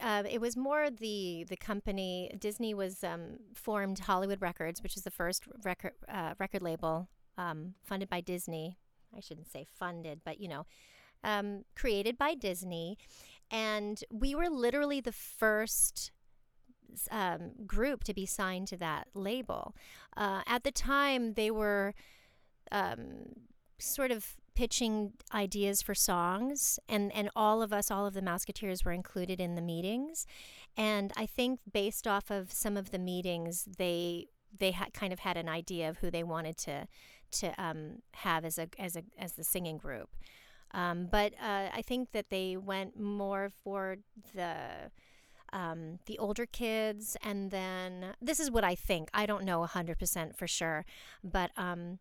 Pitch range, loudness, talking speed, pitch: 180-215 Hz, -36 LUFS, 165 wpm, 195 Hz